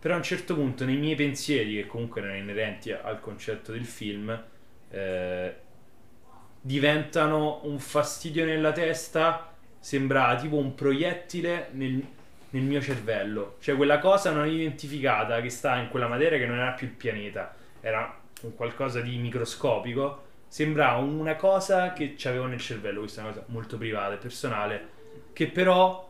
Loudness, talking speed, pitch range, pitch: -28 LUFS, 160 wpm, 115-150 Hz, 135 Hz